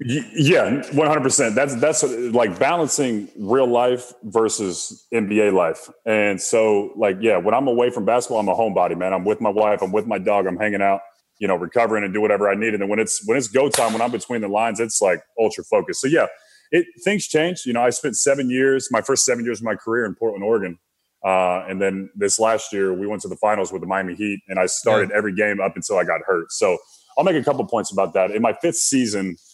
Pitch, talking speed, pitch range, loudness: 110 Hz, 240 wpm, 100-125 Hz, -20 LUFS